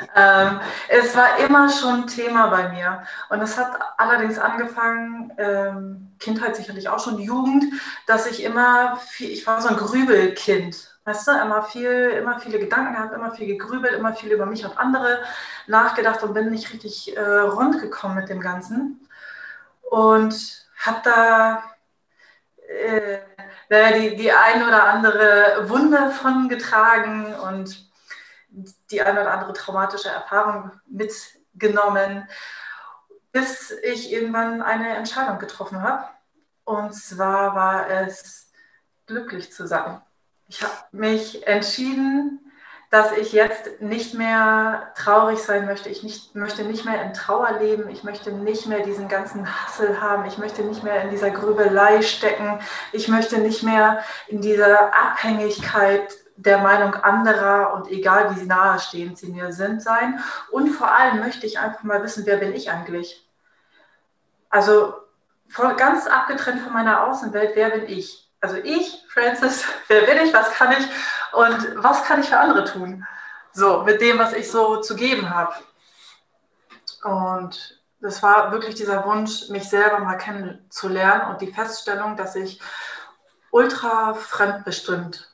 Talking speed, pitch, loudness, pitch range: 145 wpm, 215 Hz, -19 LUFS, 200-230 Hz